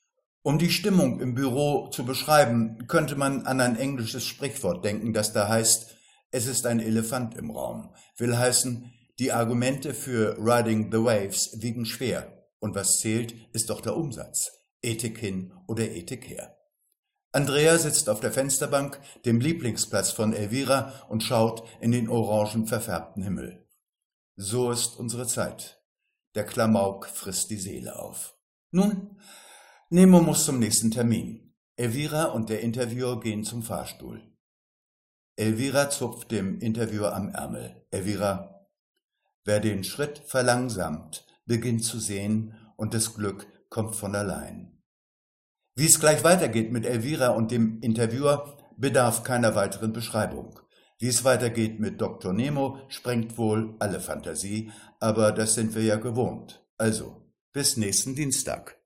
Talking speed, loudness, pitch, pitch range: 140 wpm, -26 LUFS, 115 Hz, 110-130 Hz